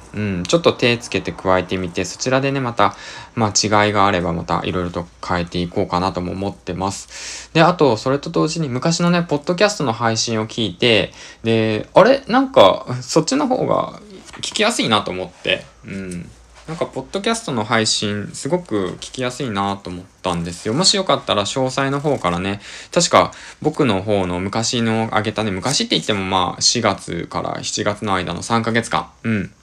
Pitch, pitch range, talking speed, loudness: 110 Hz, 95-130 Hz, 360 characters per minute, -18 LUFS